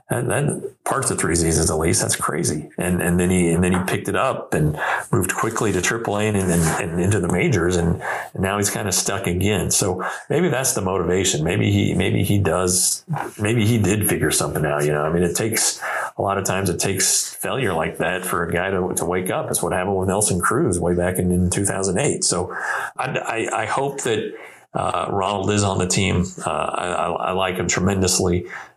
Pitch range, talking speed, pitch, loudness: 90-100 Hz, 225 wpm, 90 Hz, -20 LUFS